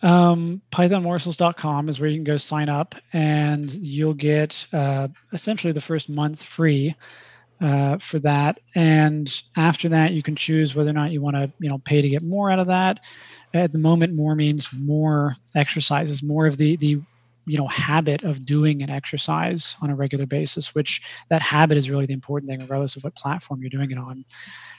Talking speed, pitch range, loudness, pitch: 195 wpm, 145-160 Hz, -22 LUFS, 150 Hz